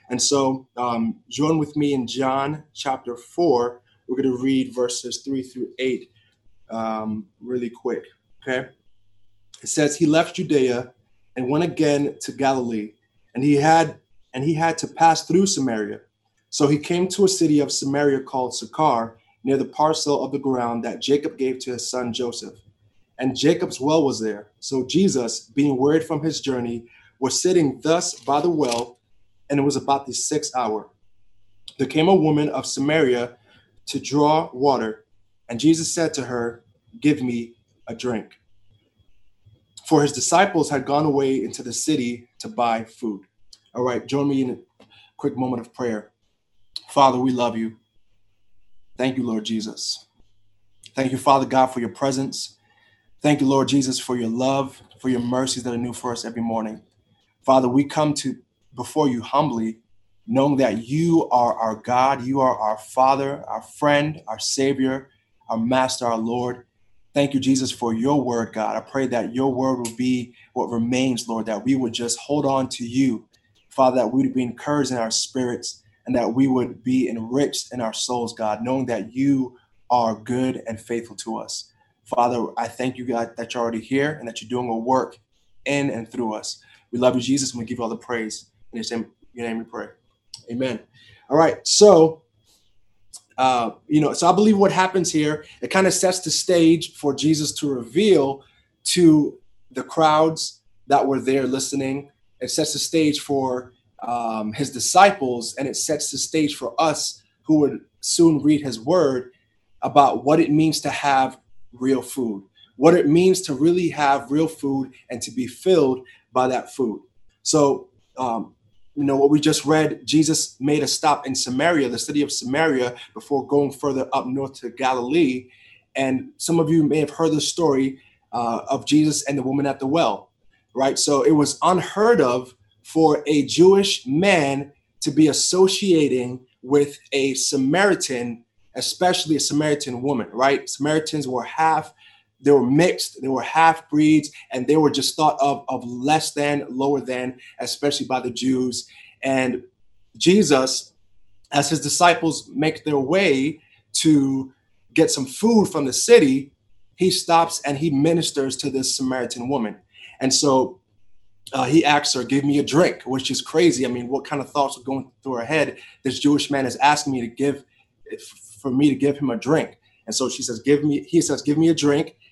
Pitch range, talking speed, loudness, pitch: 115-145 Hz, 180 wpm, -21 LUFS, 130 Hz